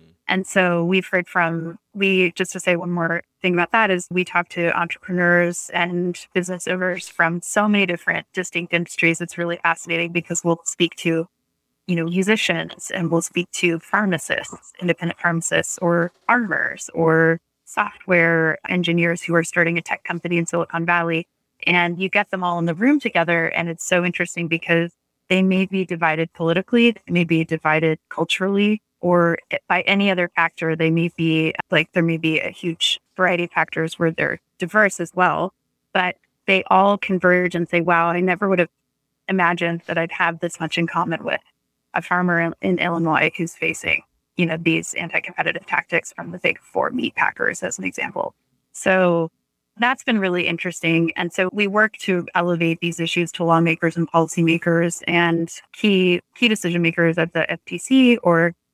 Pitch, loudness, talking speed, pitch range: 175 Hz, -20 LUFS, 175 wpm, 165-185 Hz